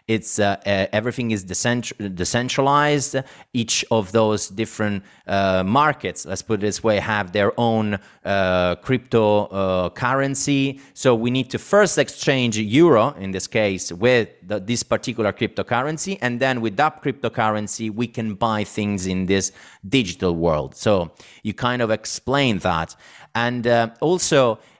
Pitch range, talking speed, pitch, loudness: 100-125 Hz, 150 wpm, 115 Hz, -21 LUFS